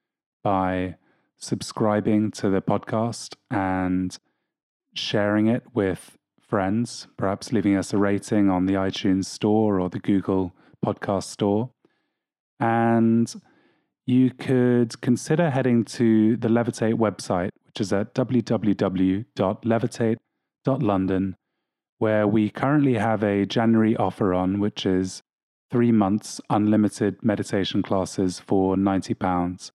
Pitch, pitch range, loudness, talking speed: 105 Hz, 95-115 Hz, -23 LUFS, 110 wpm